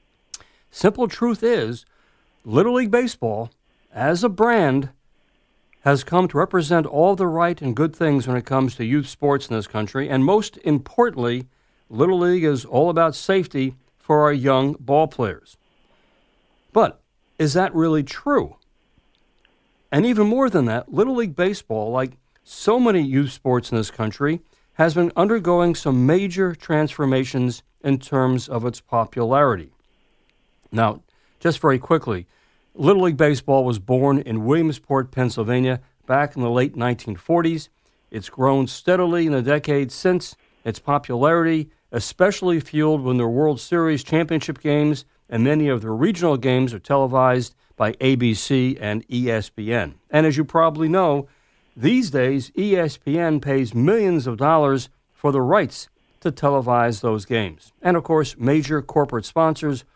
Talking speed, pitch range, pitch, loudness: 145 wpm, 125-165 Hz, 140 Hz, -20 LUFS